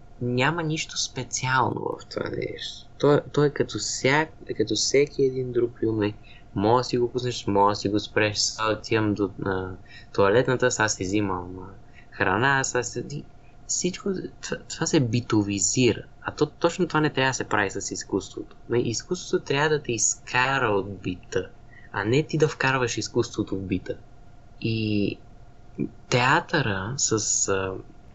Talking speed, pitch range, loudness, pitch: 145 wpm, 105-135 Hz, -25 LUFS, 120 Hz